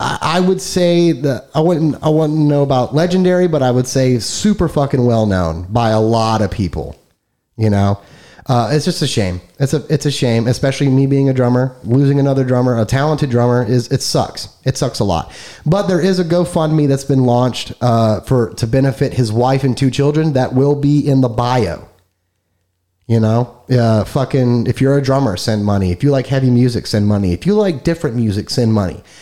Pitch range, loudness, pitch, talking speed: 110-145 Hz, -15 LUFS, 130 Hz, 205 wpm